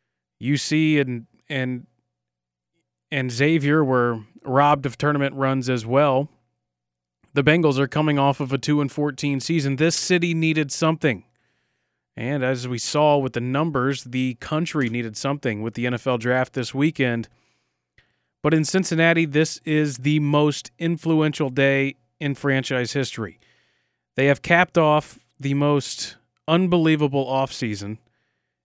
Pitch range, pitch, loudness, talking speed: 120-150 Hz, 140 Hz, -22 LUFS, 135 wpm